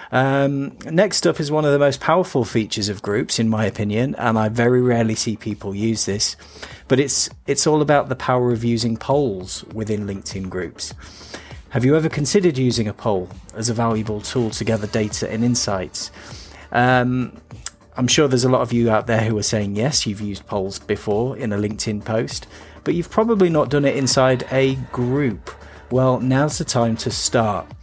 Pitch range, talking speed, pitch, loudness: 105-135 Hz, 190 wpm, 115 Hz, -20 LUFS